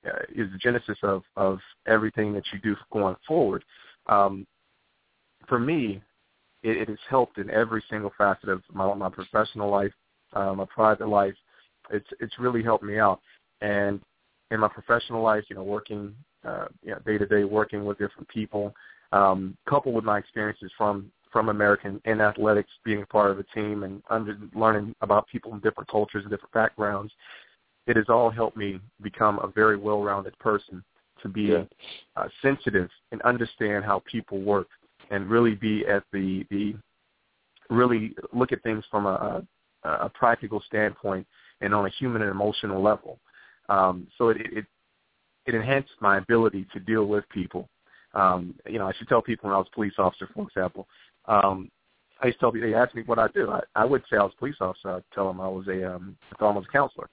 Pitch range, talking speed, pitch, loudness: 100-110 Hz, 190 wpm, 105 Hz, -26 LUFS